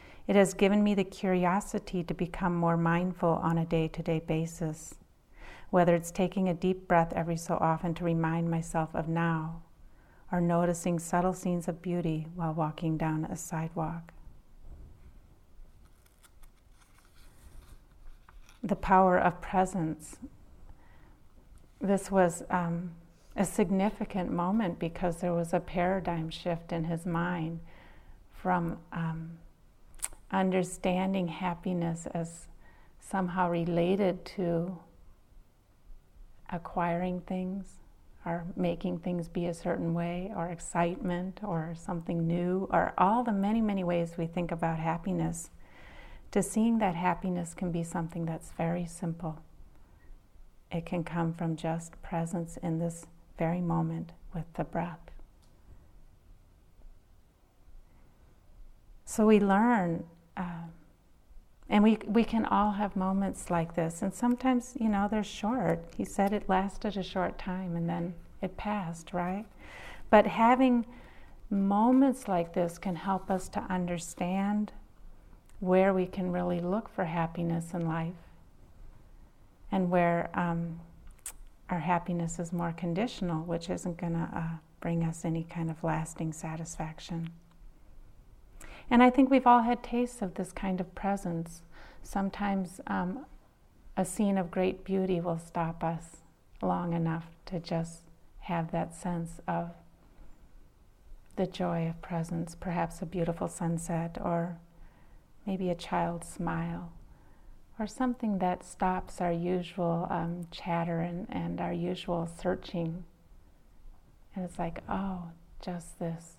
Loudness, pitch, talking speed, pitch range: -31 LUFS, 170 Hz, 125 wpm, 165-185 Hz